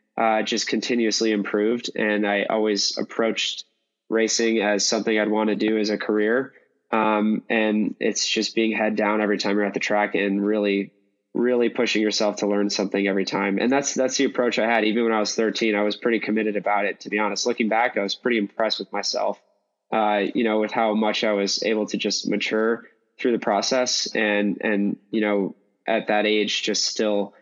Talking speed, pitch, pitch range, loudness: 205 wpm, 105 Hz, 105-110 Hz, -22 LUFS